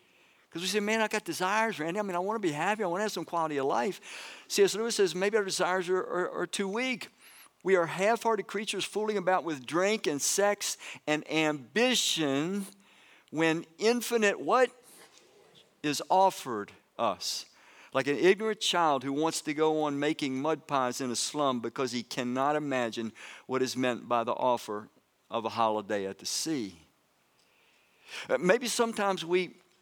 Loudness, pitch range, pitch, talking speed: -30 LUFS, 140-205 Hz, 175 Hz, 175 wpm